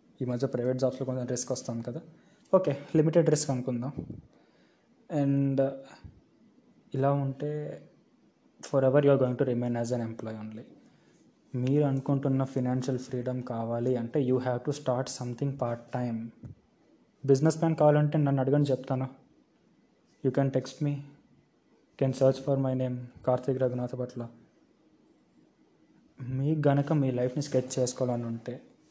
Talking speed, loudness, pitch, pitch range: 135 wpm, -29 LUFS, 130 Hz, 125-140 Hz